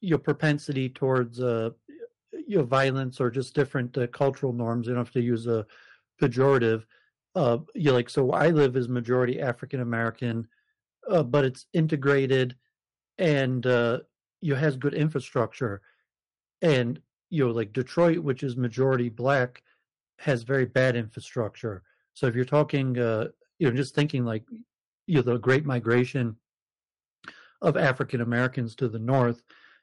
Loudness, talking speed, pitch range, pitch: -26 LUFS, 145 wpm, 120-145 Hz, 130 Hz